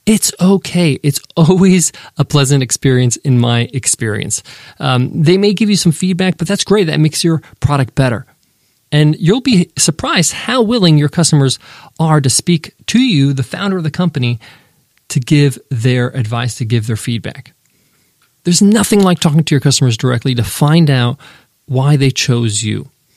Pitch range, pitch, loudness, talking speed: 130-170 Hz, 145 Hz, -13 LUFS, 170 wpm